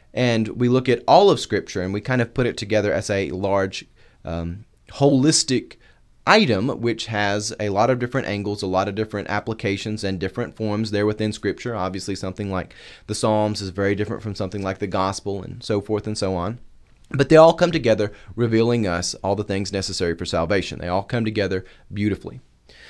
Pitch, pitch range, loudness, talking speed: 105 Hz, 95-115 Hz, -21 LUFS, 195 wpm